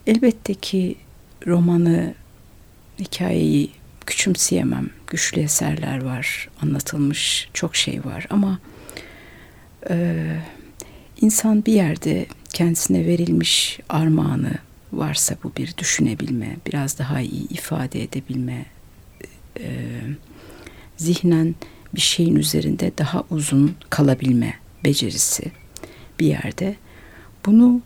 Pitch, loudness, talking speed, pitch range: 150 Hz, -20 LUFS, 90 wpm, 125-175 Hz